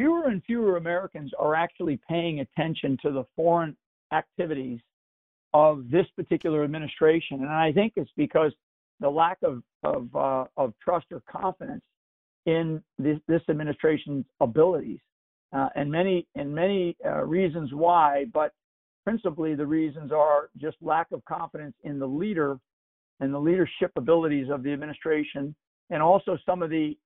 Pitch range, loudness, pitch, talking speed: 145-170 Hz, -26 LUFS, 155 Hz, 150 wpm